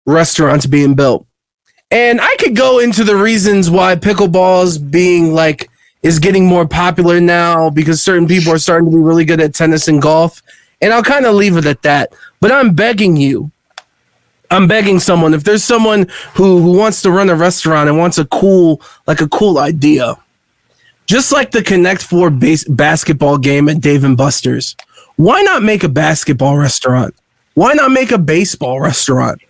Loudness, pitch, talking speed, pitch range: -10 LUFS, 170 Hz, 180 wpm, 155-195 Hz